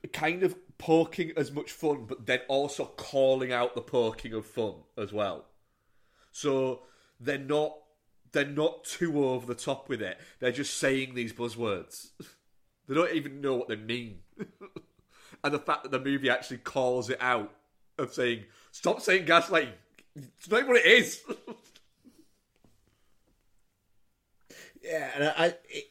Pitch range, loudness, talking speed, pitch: 125-155 Hz, -29 LUFS, 150 wpm, 140 Hz